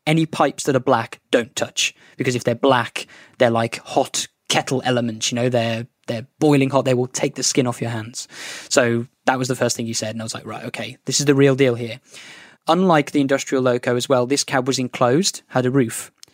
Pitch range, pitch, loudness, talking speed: 120-140 Hz, 130 Hz, -20 LUFS, 230 wpm